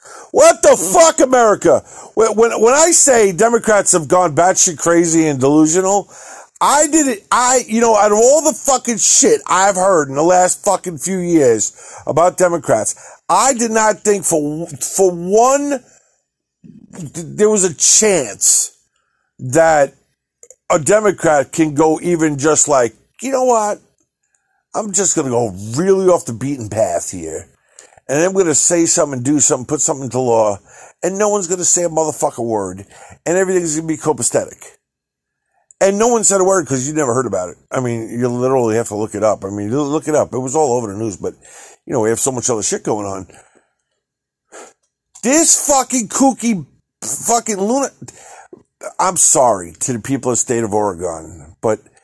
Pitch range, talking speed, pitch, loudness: 140-220 Hz, 180 wpm, 175 Hz, -14 LUFS